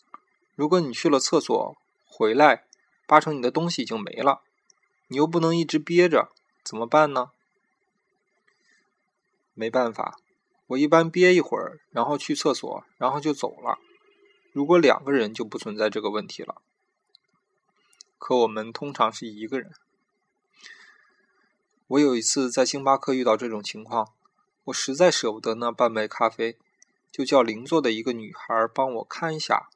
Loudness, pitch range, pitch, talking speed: -24 LUFS, 115-165 Hz, 135 Hz, 230 characters per minute